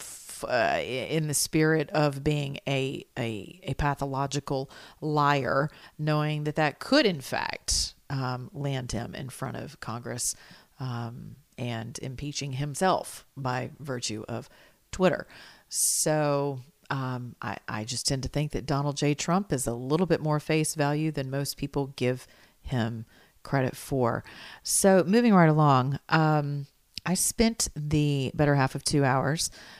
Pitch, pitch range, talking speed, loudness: 140 Hz, 130-150 Hz, 145 wpm, -27 LUFS